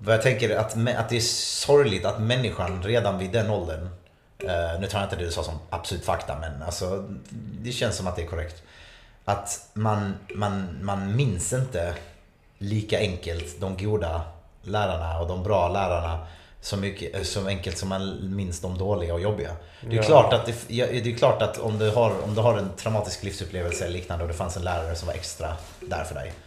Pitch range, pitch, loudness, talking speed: 85-105 Hz, 95 Hz, -26 LUFS, 205 wpm